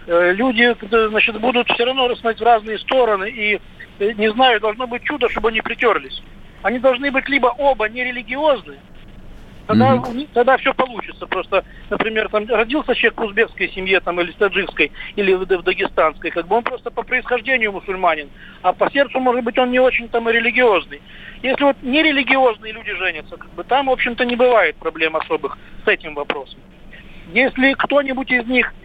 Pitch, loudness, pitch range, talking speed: 240 Hz, -17 LUFS, 205-255 Hz, 175 wpm